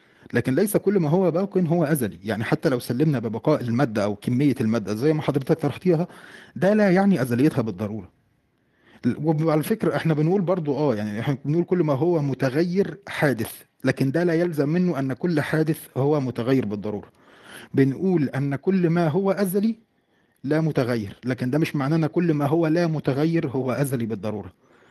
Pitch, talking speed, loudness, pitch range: 150 Hz, 175 wpm, -23 LUFS, 130-170 Hz